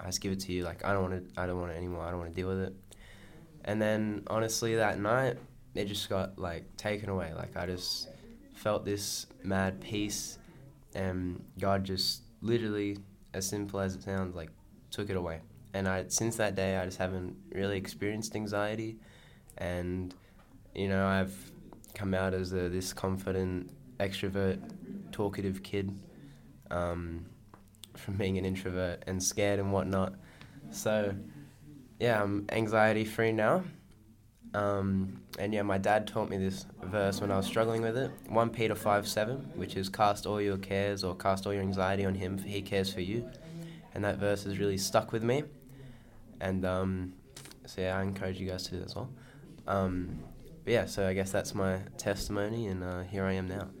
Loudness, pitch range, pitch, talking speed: -33 LUFS, 95-105 Hz, 100 Hz, 185 wpm